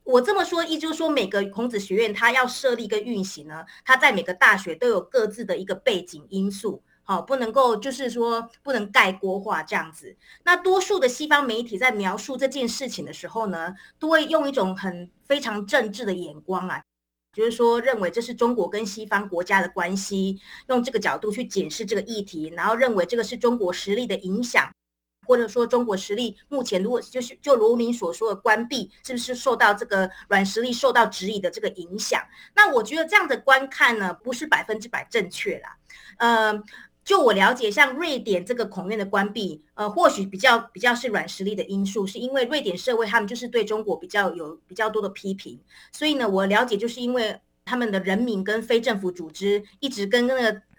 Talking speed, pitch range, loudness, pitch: 315 characters per minute, 195-255 Hz, -23 LUFS, 225 Hz